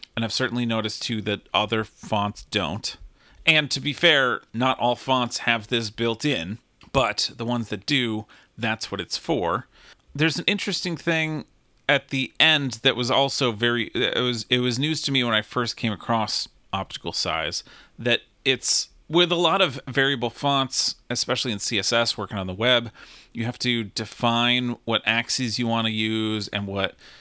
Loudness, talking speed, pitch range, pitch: -23 LUFS, 180 wpm, 110-135 Hz, 120 Hz